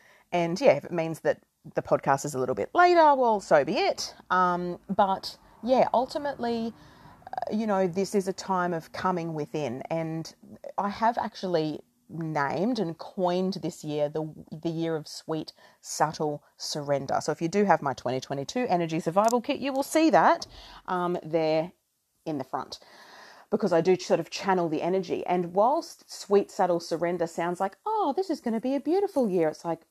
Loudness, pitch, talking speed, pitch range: -27 LUFS, 180 Hz, 185 wpm, 160-215 Hz